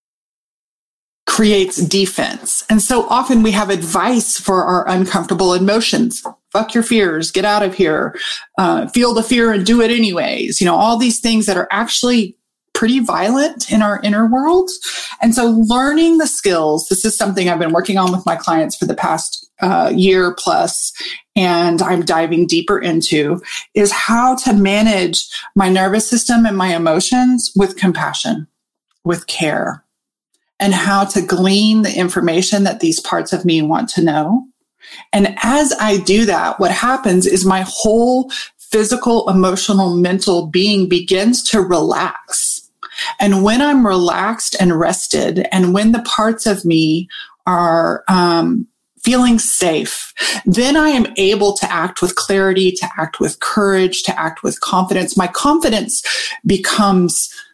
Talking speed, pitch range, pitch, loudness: 155 wpm, 185-235 Hz, 200 Hz, -14 LUFS